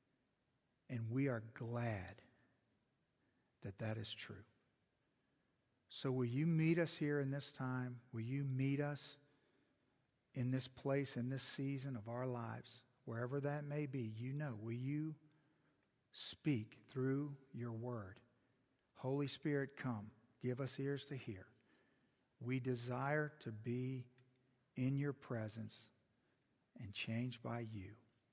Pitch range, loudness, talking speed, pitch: 120-140 Hz, -44 LUFS, 130 wpm, 125 Hz